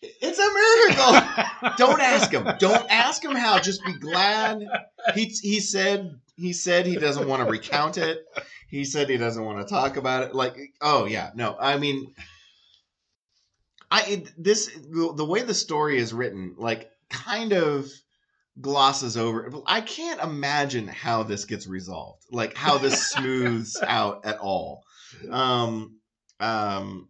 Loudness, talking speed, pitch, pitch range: -23 LUFS, 150 wpm, 145 Hz, 115-195 Hz